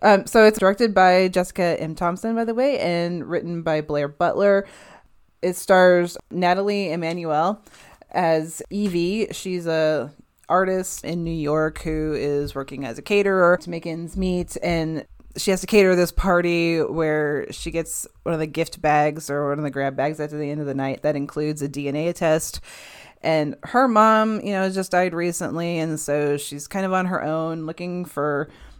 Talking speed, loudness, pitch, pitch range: 185 wpm, -22 LUFS, 170 Hz, 150-185 Hz